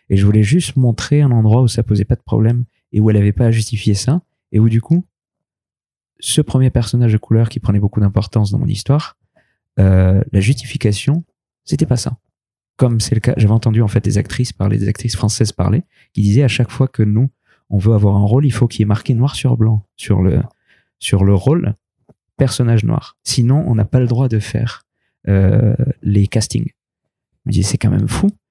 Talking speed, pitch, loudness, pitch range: 225 wpm, 115 Hz, -15 LUFS, 105-130 Hz